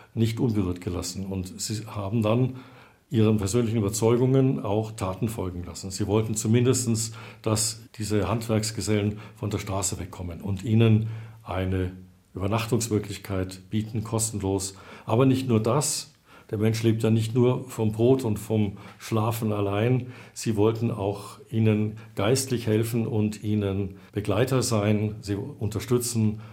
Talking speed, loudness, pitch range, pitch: 130 wpm, -26 LUFS, 100-115 Hz, 110 Hz